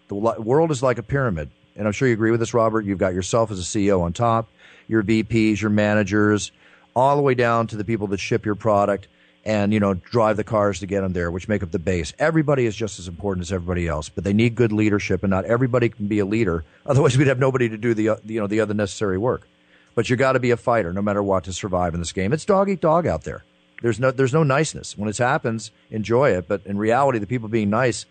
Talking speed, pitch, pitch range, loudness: 265 wpm, 110 Hz, 100-120 Hz, -21 LUFS